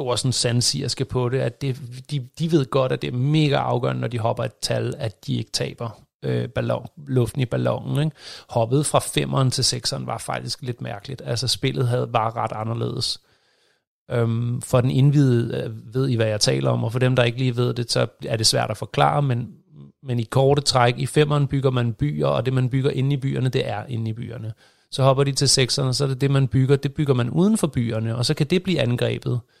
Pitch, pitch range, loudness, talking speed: 130 Hz, 120-140 Hz, -22 LUFS, 235 wpm